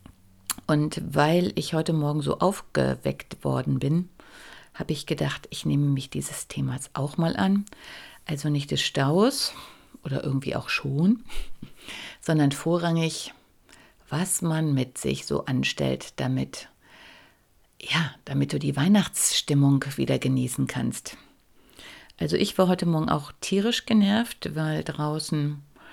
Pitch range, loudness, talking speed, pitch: 135-185 Hz, -26 LUFS, 125 wpm, 150 Hz